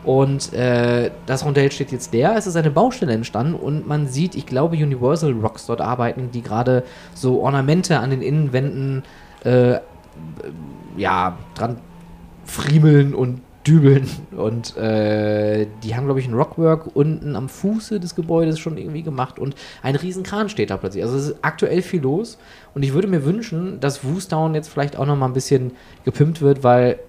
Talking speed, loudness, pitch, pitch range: 175 wpm, -19 LUFS, 140 Hz, 125-155 Hz